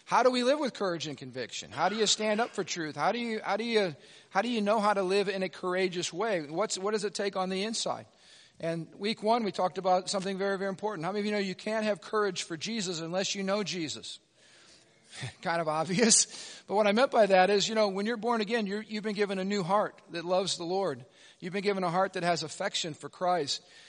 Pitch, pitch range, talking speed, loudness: 195 Hz, 180-215 Hz, 255 wpm, -30 LUFS